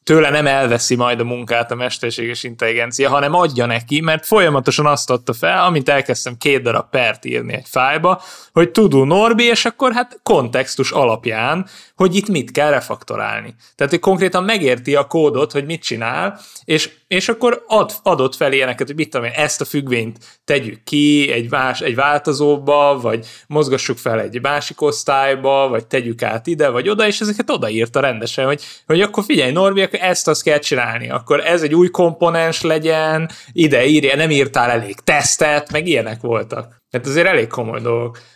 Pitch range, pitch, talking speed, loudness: 120-165 Hz, 145 Hz, 175 wpm, -16 LUFS